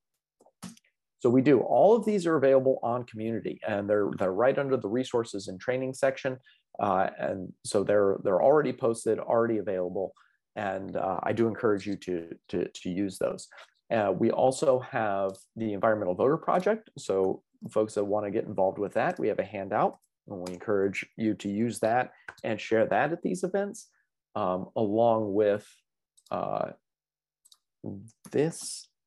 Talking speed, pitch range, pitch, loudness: 165 wpm, 100-130 Hz, 110 Hz, -28 LUFS